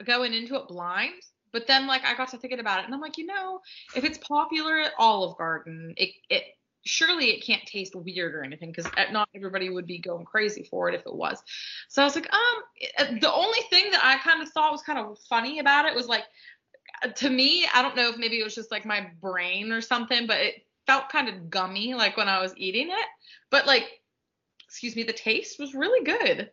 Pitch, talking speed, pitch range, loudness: 245 Hz, 230 wpm, 205-310 Hz, -25 LUFS